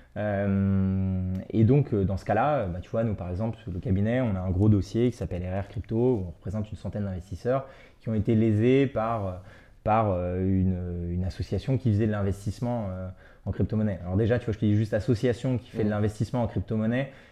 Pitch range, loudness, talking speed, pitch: 95-115 Hz, -27 LUFS, 205 wpm, 105 Hz